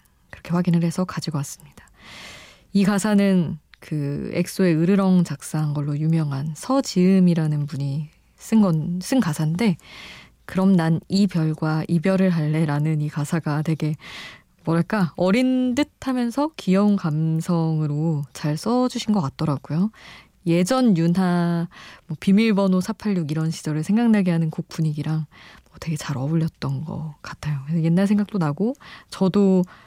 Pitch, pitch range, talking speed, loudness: 170 Hz, 155-195 Hz, 285 characters per minute, -22 LUFS